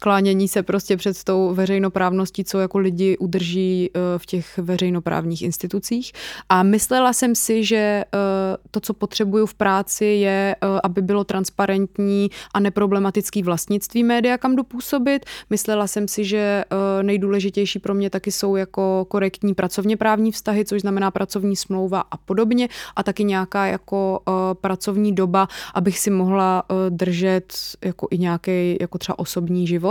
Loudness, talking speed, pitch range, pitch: -20 LUFS, 140 wpm, 190-205 Hz, 195 Hz